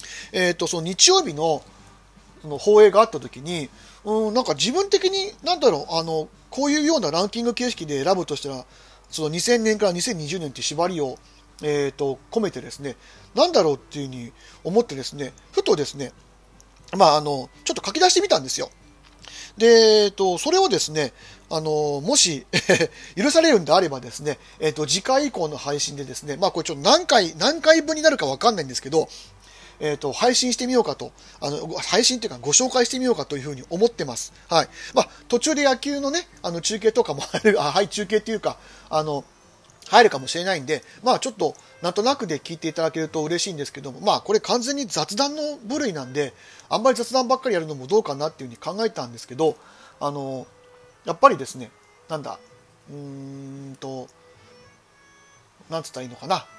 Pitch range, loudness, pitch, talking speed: 145-240 Hz, -21 LUFS, 170 Hz, 365 characters per minute